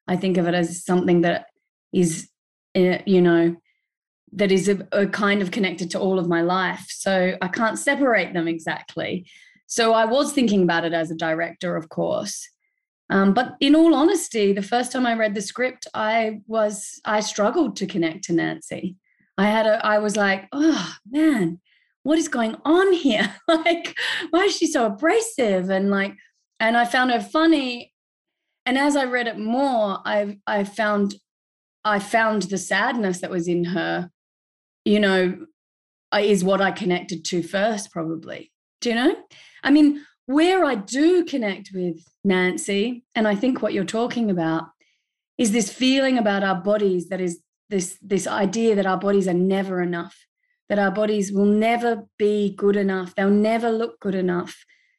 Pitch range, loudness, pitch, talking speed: 185-245 Hz, -21 LUFS, 205 Hz, 175 wpm